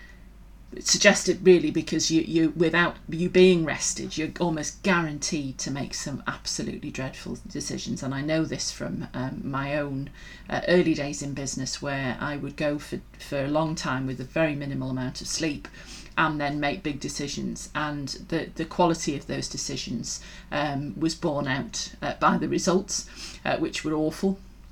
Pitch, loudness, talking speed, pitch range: 155 Hz, -26 LUFS, 170 wpm, 140-165 Hz